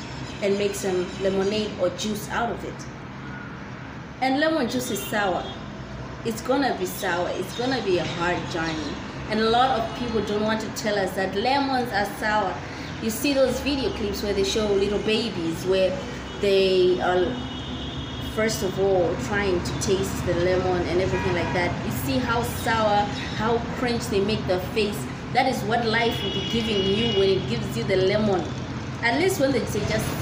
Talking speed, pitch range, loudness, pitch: 185 wpm, 185-225 Hz, -24 LUFS, 200 Hz